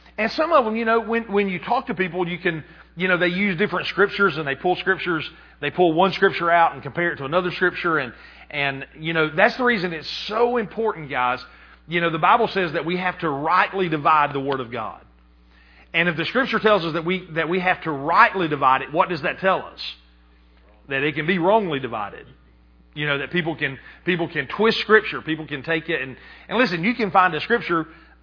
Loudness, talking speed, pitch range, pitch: -21 LUFS, 230 wpm, 145-195 Hz, 170 Hz